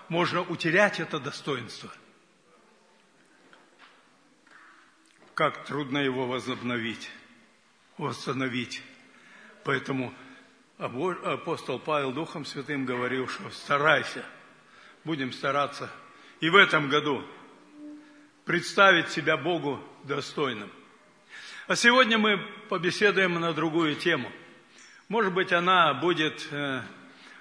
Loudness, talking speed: -26 LUFS, 85 wpm